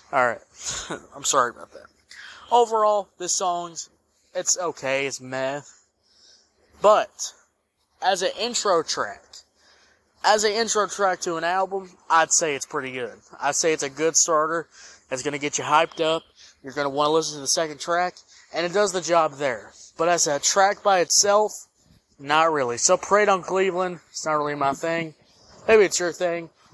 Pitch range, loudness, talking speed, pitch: 145-190 Hz, -22 LUFS, 175 wpm, 165 Hz